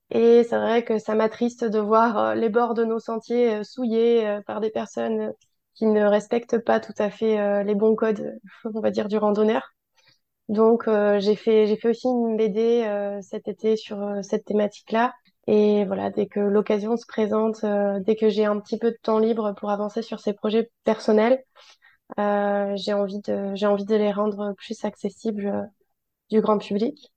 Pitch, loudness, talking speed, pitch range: 215 Hz, -23 LUFS, 175 wpm, 205-230 Hz